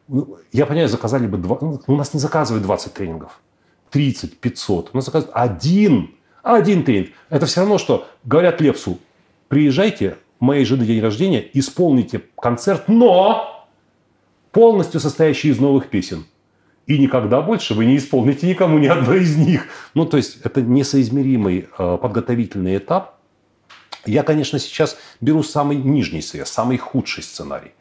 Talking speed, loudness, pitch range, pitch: 145 wpm, -17 LUFS, 120-160 Hz, 140 Hz